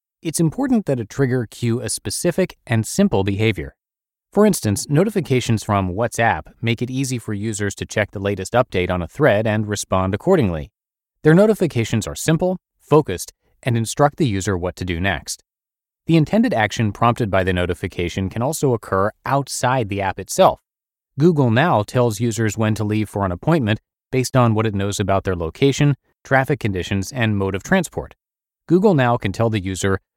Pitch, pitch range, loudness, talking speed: 115 Hz, 100-140 Hz, -19 LUFS, 175 wpm